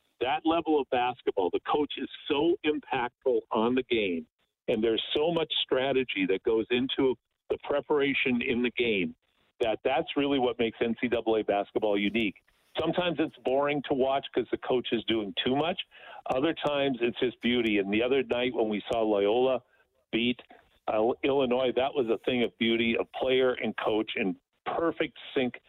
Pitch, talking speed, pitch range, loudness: 130 Hz, 175 wpm, 115-145 Hz, -28 LUFS